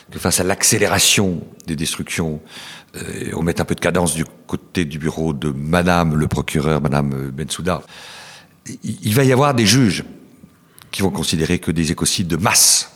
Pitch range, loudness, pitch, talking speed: 75-90 Hz, -17 LUFS, 80 Hz, 170 wpm